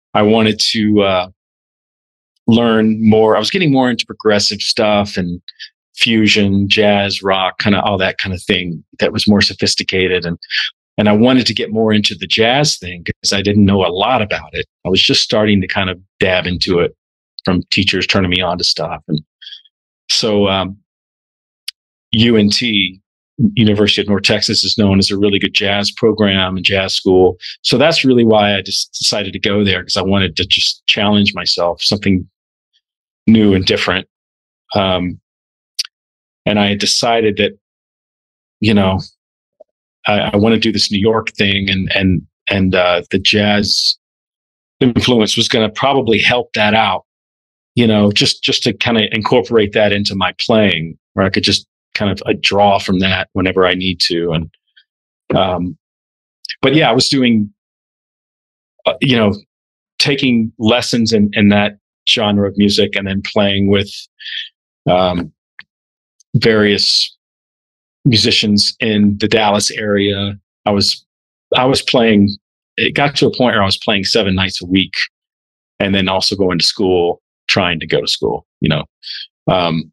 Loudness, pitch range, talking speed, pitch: -13 LUFS, 95-105 Hz, 165 wpm, 100 Hz